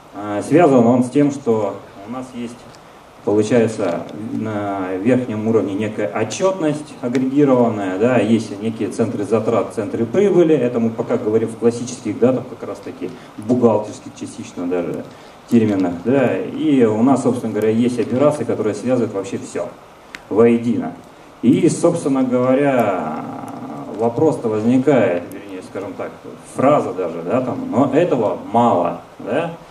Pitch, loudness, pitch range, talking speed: 115 Hz, -17 LUFS, 105-130 Hz, 130 wpm